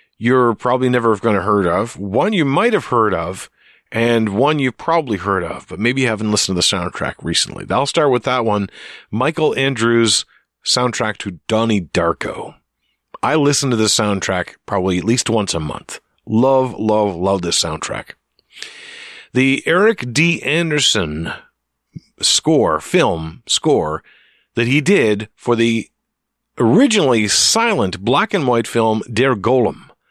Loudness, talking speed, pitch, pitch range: -16 LUFS, 145 wpm, 115 Hz, 100-130 Hz